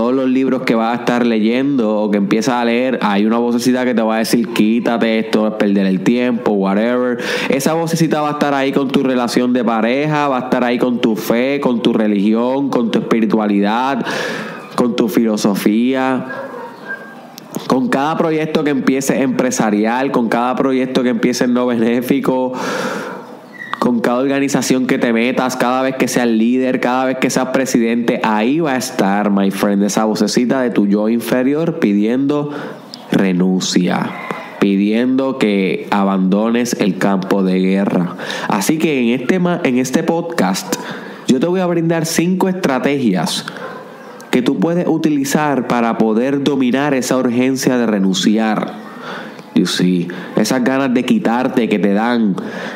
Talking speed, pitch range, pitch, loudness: 160 wpm, 110-145 Hz, 125 Hz, -15 LUFS